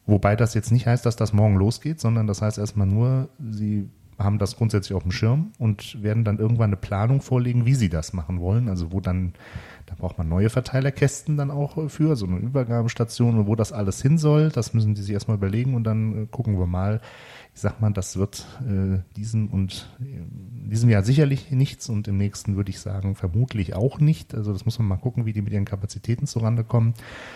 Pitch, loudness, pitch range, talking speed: 110 Hz, -23 LUFS, 100-120 Hz, 220 wpm